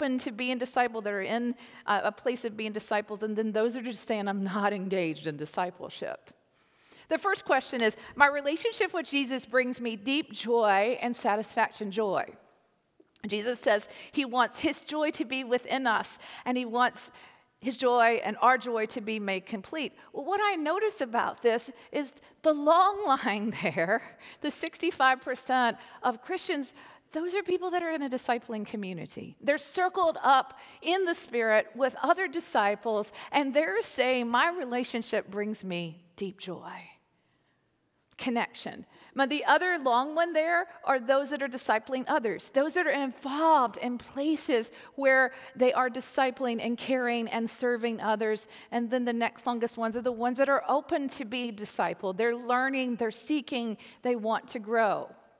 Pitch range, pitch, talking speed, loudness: 225-285 Hz, 250 Hz, 165 wpm, -29 LUFS